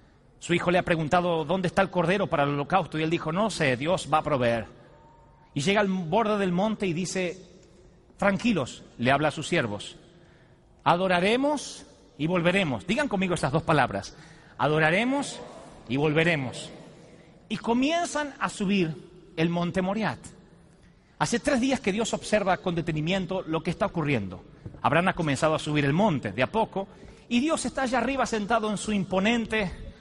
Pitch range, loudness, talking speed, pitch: 155-205 Hz, -26 LUFS, 170 wpm, 180 Hz